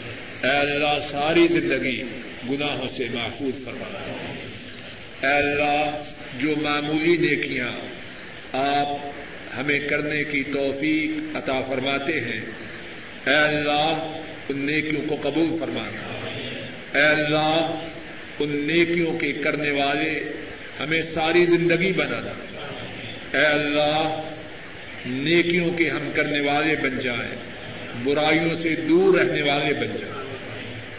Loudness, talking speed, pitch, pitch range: -23 LUFS, 105 wpm, 150 Hz, 135-155 Hz